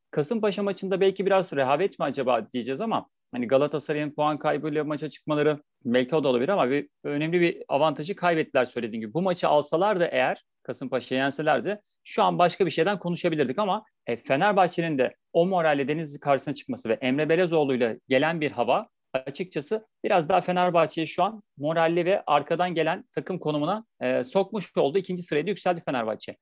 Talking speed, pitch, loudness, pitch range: 165 wpm, 155 Hz, -26 LUFS, 145-180 Hz